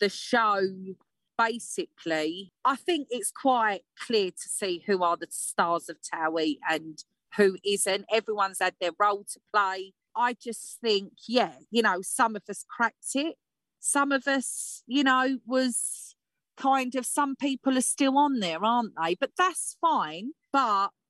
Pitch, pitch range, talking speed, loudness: 220 Hz, 190-265 Hz, 160 wpm, -27 LUFS